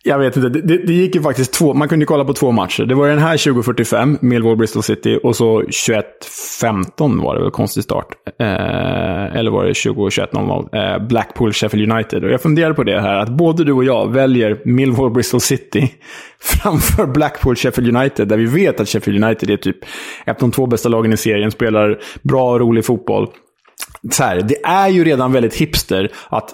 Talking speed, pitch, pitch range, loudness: 195 wpm, 125 Hz, 110-140 Hz, -15 LUFS